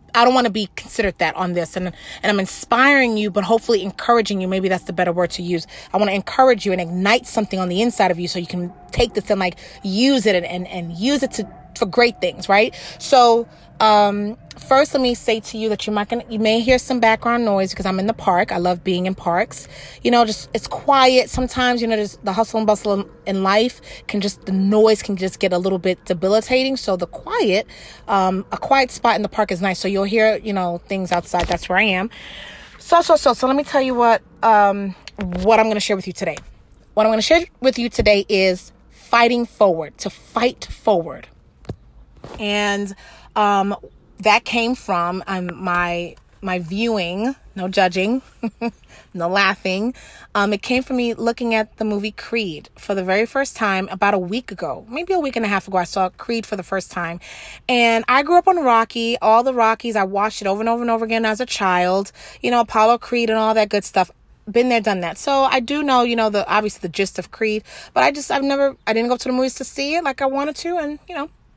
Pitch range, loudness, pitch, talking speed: 190-235 Hz, -18 LUFS, 215 Hz, 230 wpm